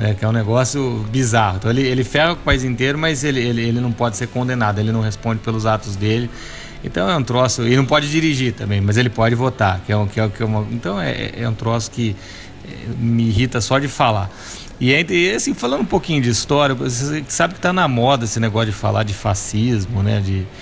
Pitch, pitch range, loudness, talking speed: 115 Hz, 110-130 Hz, -18 LUFS, 235 wpm